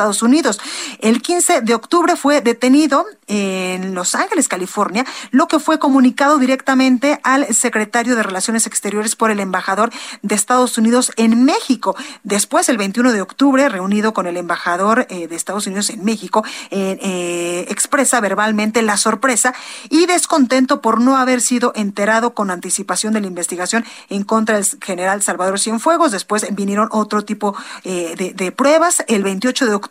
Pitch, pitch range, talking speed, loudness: 225 Hz, 200-260 Hz, 165 wpm, -15 LUFS